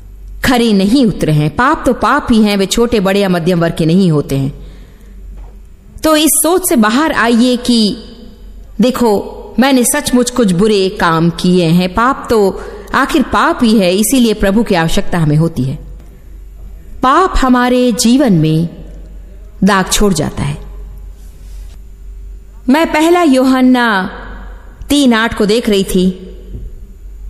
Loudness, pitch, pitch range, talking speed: -11 LUFS, 205 Hz, 160-245 Hz, 140 wpm